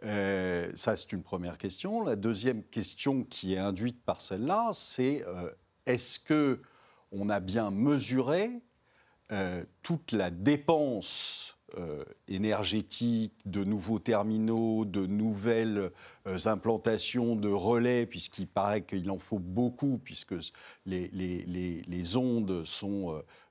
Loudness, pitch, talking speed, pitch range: -32 LUFS, 110 Hz, 130 wpm, 95-120 Hz